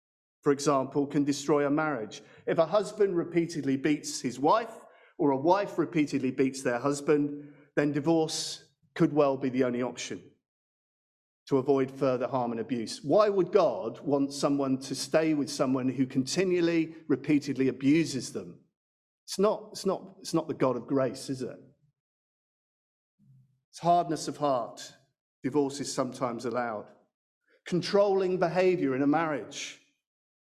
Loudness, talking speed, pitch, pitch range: -29 LUFS, 145 wpm, 145 Hz, 135-160 Hz